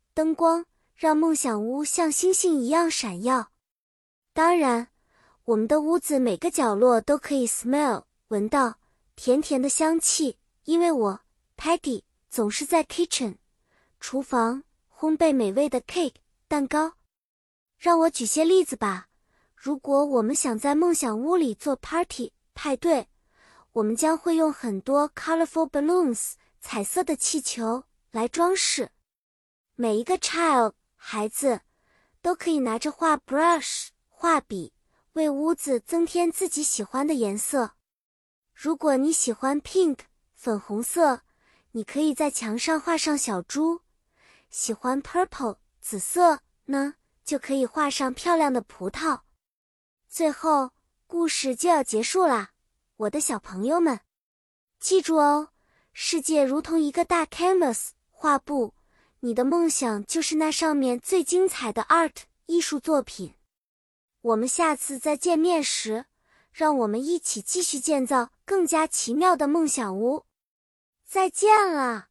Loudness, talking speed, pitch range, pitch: -24 LUFS, 235 characters per minute, 245-330 Hz, 295 Hz